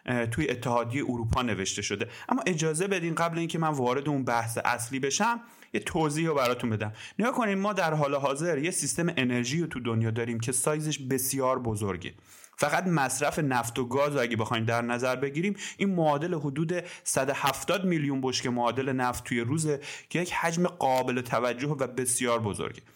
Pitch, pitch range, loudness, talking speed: 135 Hz, 125-165 Hz, -28 LUFS, 180 wpm